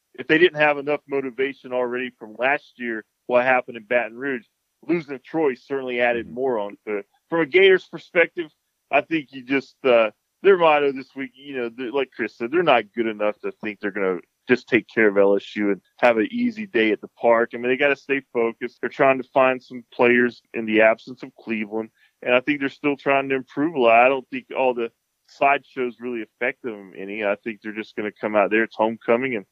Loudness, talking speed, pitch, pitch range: -22 LUFS, 230 wpm, 125 Hz, 115-140 Hz